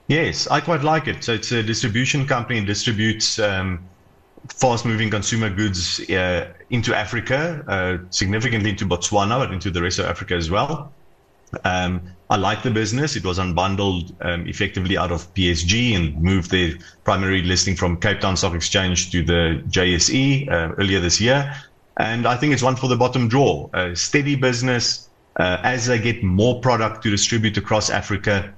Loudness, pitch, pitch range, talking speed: -20 LUFS, 105 Hz, 90-120 Hz, 175 wpm